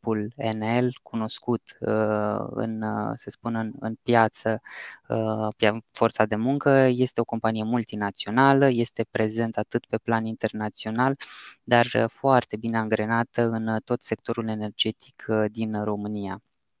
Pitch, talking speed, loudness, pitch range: 110 Hz, 110 wpm, -25 LUFS, 110-120 Hz